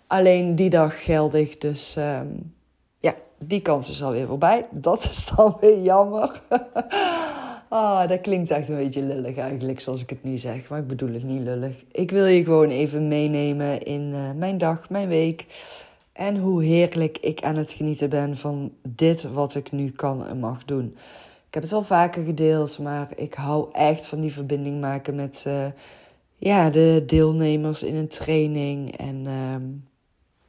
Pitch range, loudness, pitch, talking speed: 140-170 Hz, -23 LUFS, 150 Hz, 175 wpm